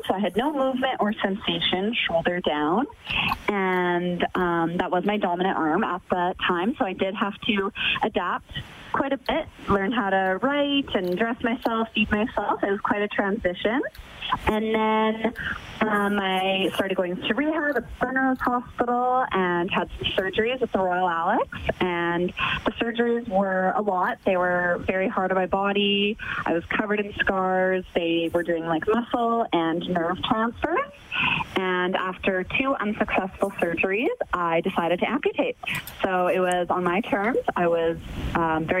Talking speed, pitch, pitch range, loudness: 165 wpm, 195 Hz, 180-230 Hz, -24 LUFS